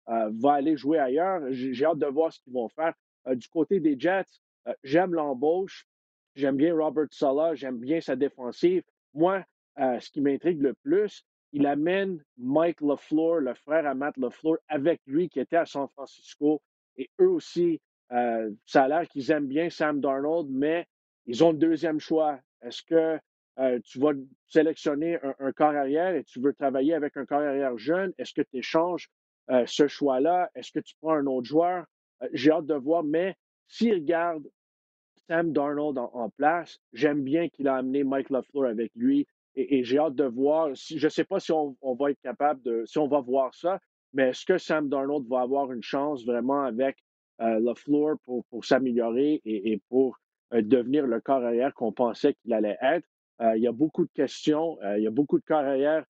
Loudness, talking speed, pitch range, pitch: -27 LUFS, 205 wpm, 130-165 Hz, 145 Hz